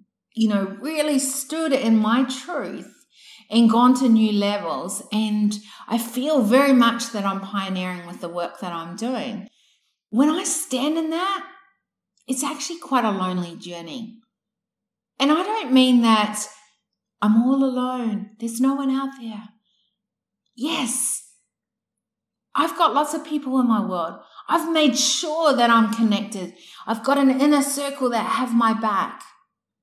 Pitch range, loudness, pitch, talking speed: 210-275 Hz, -21 LUFS, 230 Hz, 150 wpm